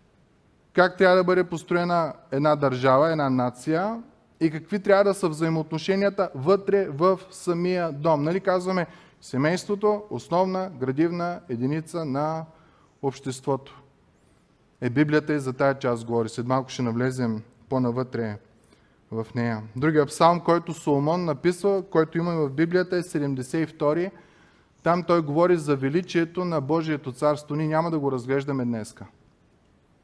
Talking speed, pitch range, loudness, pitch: 135 wpm, 135-175 Hz, -24 LUFS, 160 Hz